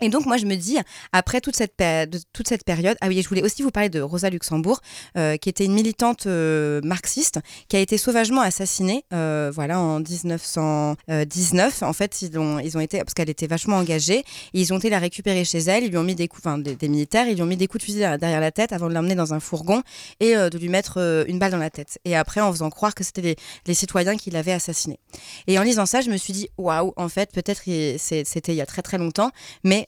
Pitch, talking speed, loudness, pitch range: 185 Hz, 265 wpm, -22 LUFS, 160-205 Hz